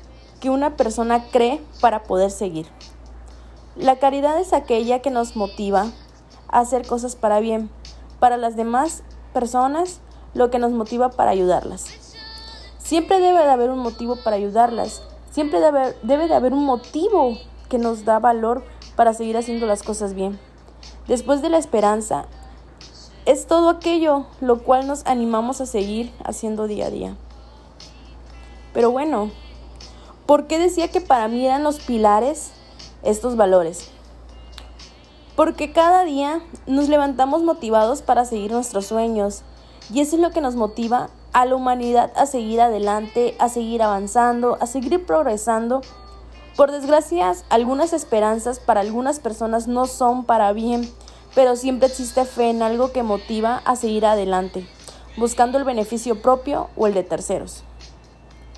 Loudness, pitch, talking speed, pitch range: -20 LUFS, 235 Hz, 145 wpm, 210-265 Hz